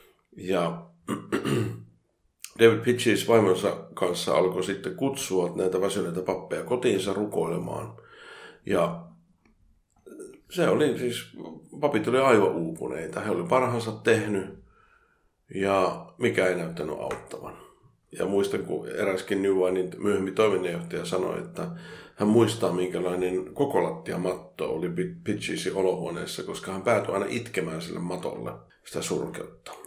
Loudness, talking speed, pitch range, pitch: -27 LUFS, 110 wpm, 90-115 Hz, 100 Hz